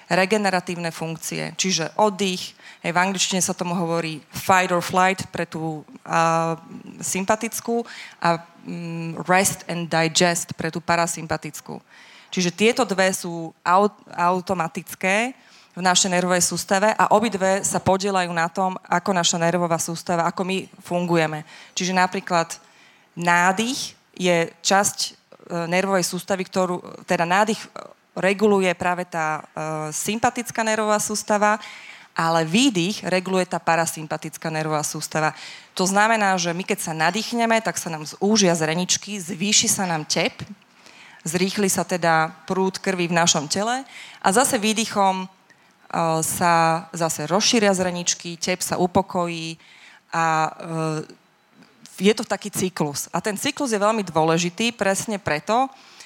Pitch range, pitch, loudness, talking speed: 165-200 Hz, 180 Hz, -22 LUFS, 130 wpm